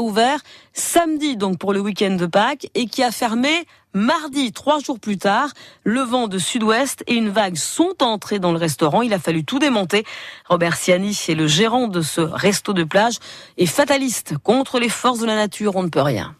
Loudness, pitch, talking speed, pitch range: -19 LUFS, 215 Hz, 205 wpm, 185-260 Hz